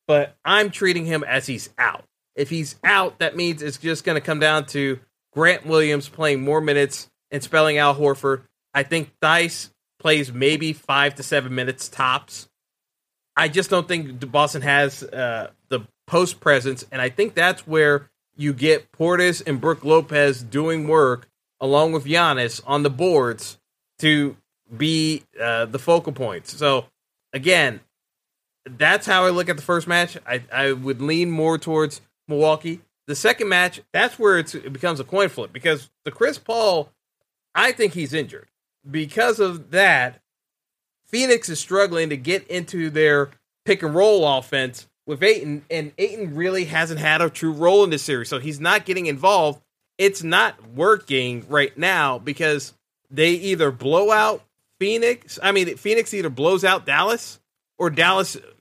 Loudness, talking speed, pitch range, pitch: -20 LUFS, 165 wpm, 140-175 Hz, 155 Hz